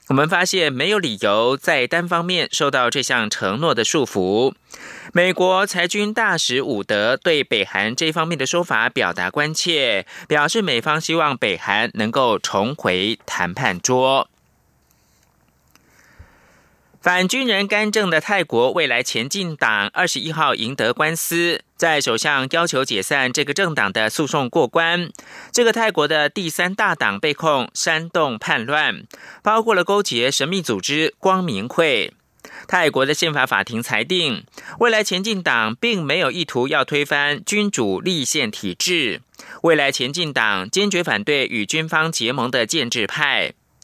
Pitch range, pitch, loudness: 130-190 Hz, 160 Hz, -18 LUFS